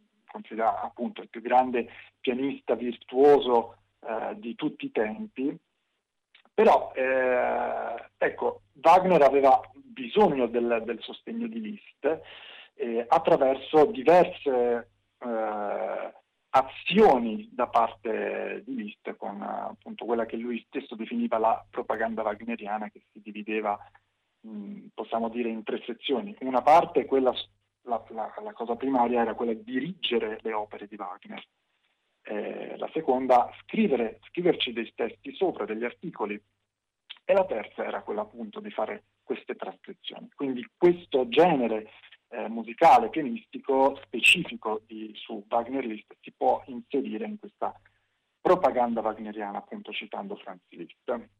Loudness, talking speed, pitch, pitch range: -27 LUFS, 125 wpm, 120 Hz, 110-160 Hz